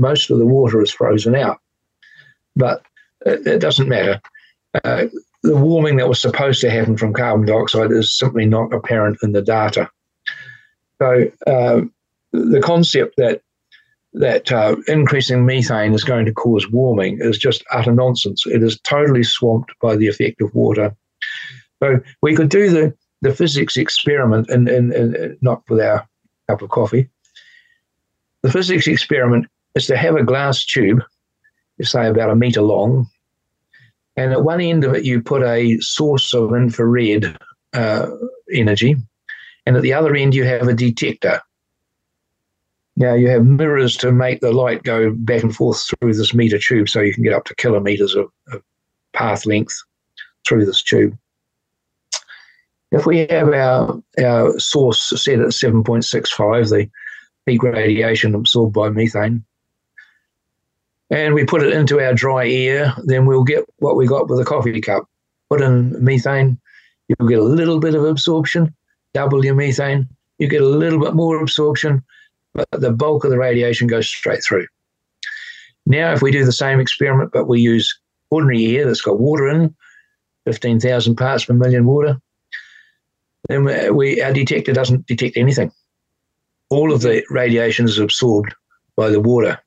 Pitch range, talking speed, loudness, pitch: 115-150 Hz, 160 wpm, -16 LUFS, 125 Hz